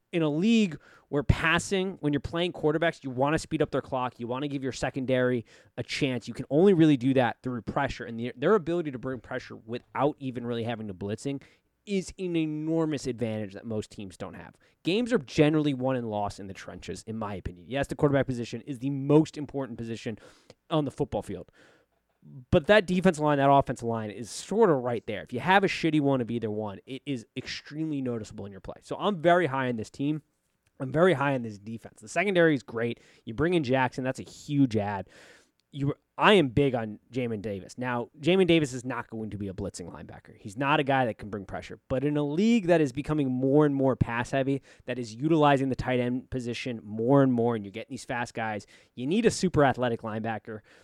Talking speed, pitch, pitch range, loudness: 225 wpm, 130 Hz, 115-150 Hz, -28 LUFS